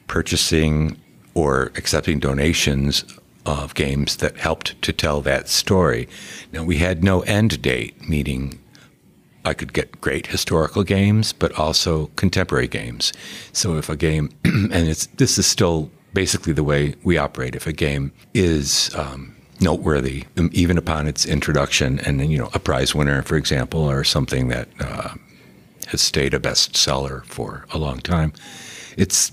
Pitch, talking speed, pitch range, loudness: 80 Hz, 155 wpm, 70-90 Hz, -20 LUFS